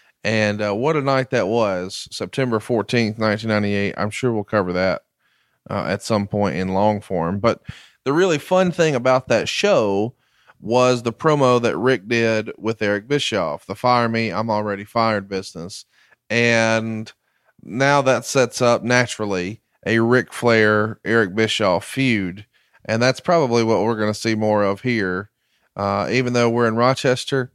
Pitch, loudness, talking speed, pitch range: 115 Hz, -19 LUFS, 165 wpm, 105-125 Hz